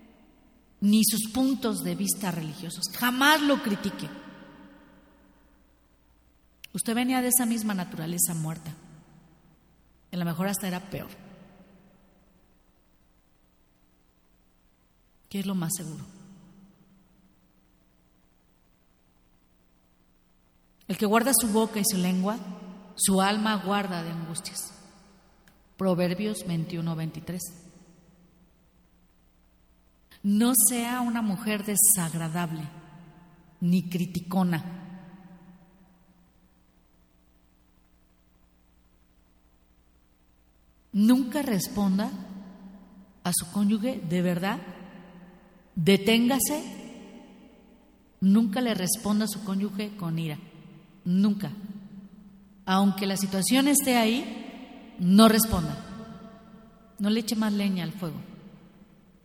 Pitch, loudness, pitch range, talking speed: 185 Hz, -26 LUFS, 165-205 Hz, 80 wpm